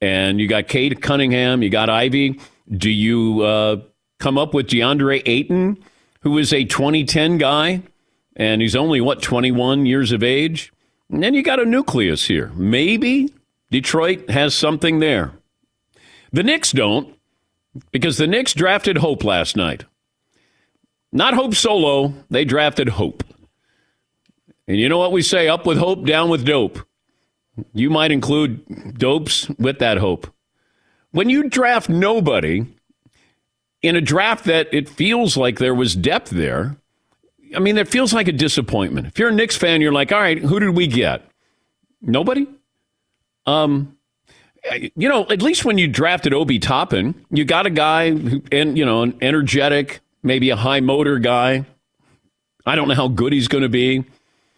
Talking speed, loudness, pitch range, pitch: 160 wpm, -17 LUFS, 125-175 Hz, 145 Hz